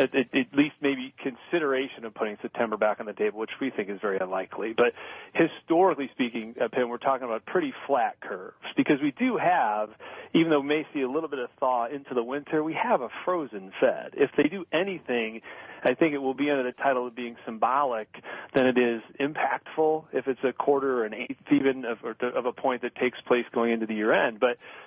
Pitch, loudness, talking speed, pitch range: 130 Hz, -27 LUFS, 210 wpm, 120-145 Hz